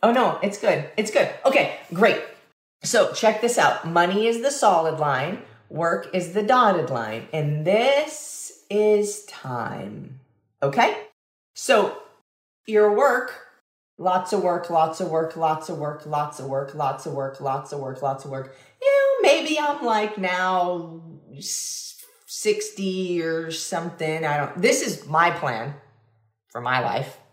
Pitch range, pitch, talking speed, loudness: 145-215 Hz, 170 Hz, 150 wpm, -22 LUFS